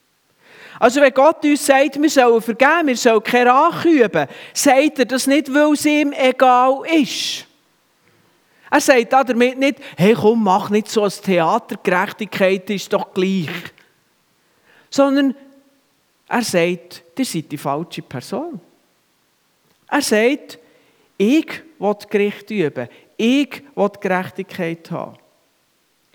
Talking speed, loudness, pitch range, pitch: 130 wpm, -16 LUFS, 195-275 Hz, 235 Hz